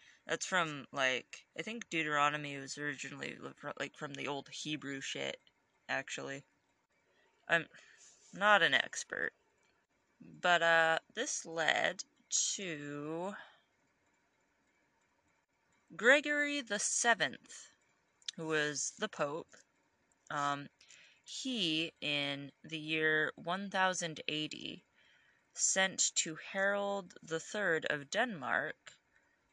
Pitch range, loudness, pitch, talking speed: 145-190 Hz, -35 LUFS, 160 Hz, 95 wpm